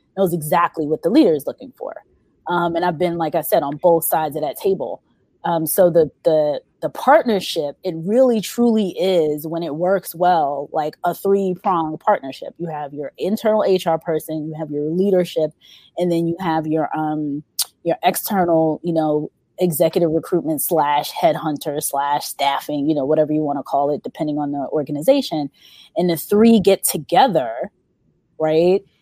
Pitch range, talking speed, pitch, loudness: 155-185 Hz, 175 wpm, 165 Hz, -19 LUFS